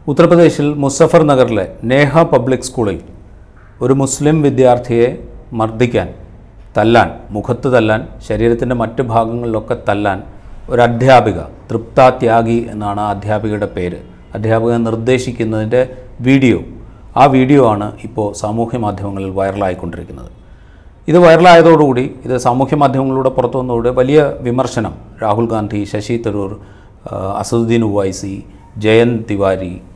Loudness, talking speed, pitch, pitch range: -13 LUFS, 100 wpm, 115 Hz, 105-130 Hz